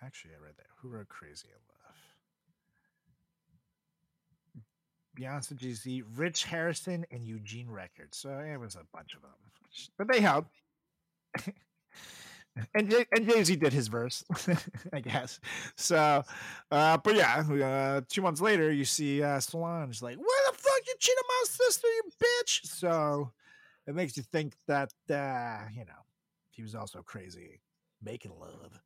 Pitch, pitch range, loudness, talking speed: 155 Hz, 130-185 Hz, -30 LUFS, 150 wpm